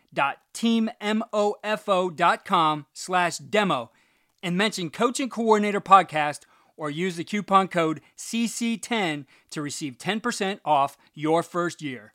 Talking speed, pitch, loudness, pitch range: 100 wpm, 185 Hz, -25 LUFS, 155-215 Hz